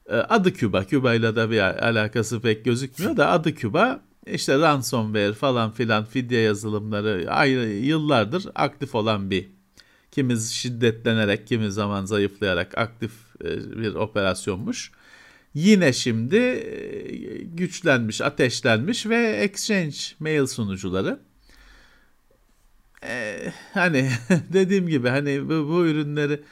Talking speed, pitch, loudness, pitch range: 105 wpm, 125 Hz, -23 LUFS, 110-155 Hz